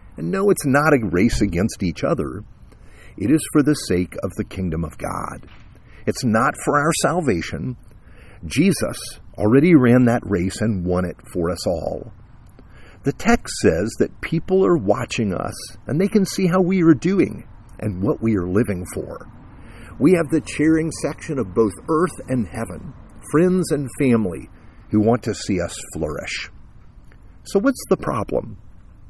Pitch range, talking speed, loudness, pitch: 100-160 Hz, 165 wpm, -20 LUFS, 115 Hz